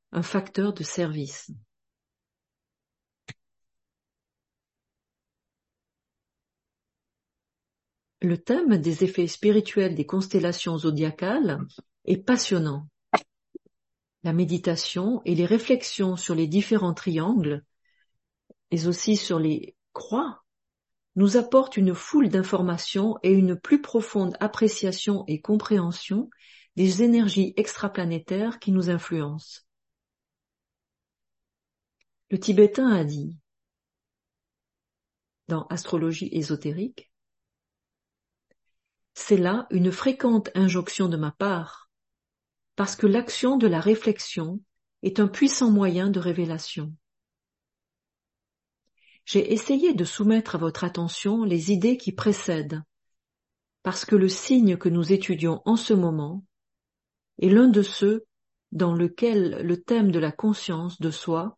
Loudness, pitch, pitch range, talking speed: -24 LUFS, 185 Hz, 165-210 Hz, 105 wpm